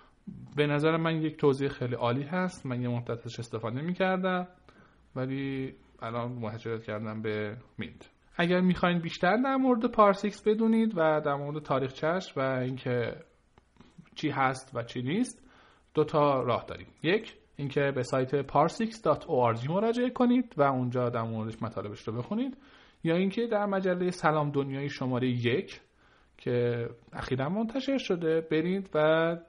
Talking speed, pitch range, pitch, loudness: 140 wpm, 125-185 Hz, 145 Hz, -29 LUFS